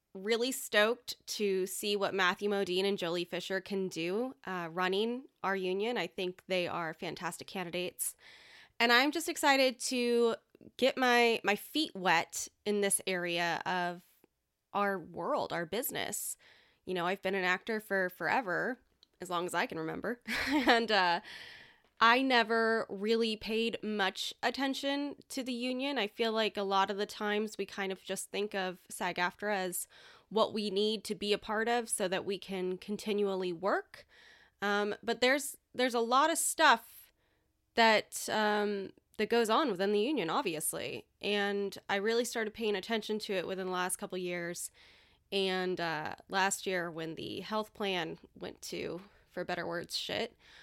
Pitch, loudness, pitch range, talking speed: 205 Hz, -33 LUFS, 185-230 Hz, 165 wpm